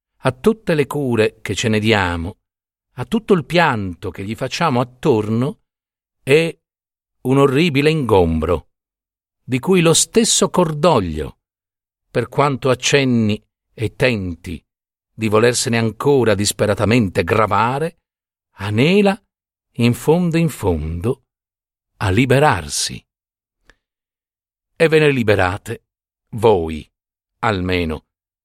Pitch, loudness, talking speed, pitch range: 115 Hz, -17 LUFS, 100 wpm, 95-145 Hz